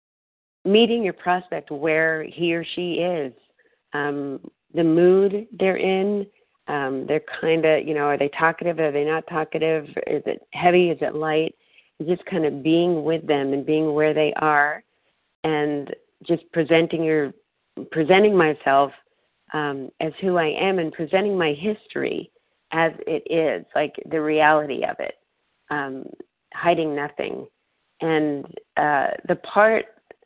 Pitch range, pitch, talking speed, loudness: 150-180 Hz, 160 Hz, 145 wpm, -22 LUFS